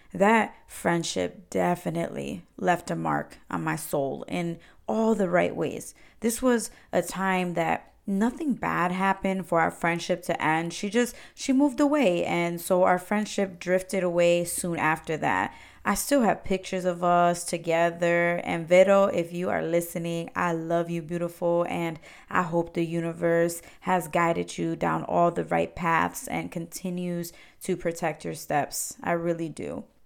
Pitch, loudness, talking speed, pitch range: 175 Hz, -26 LUFS, 160 wpm, 170-190 Hz